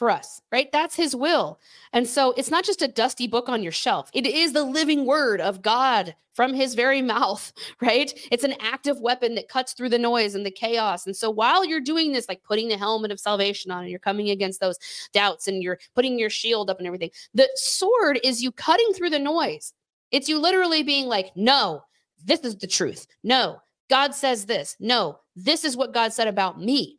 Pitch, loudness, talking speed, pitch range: 245 Hz, -23 LUFS, 220 wpm, 205-285 Hz